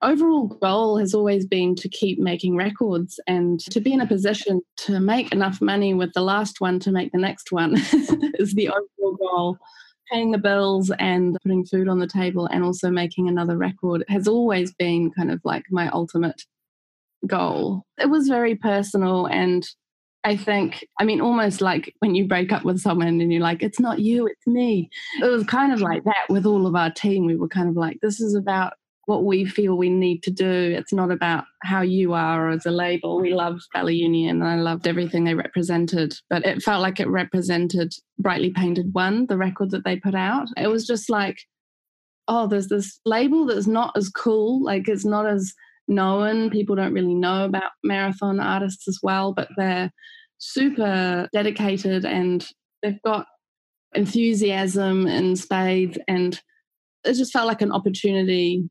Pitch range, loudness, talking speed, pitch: 180-210 Hz, -22 LUFS, 185 wpm, 190 Hz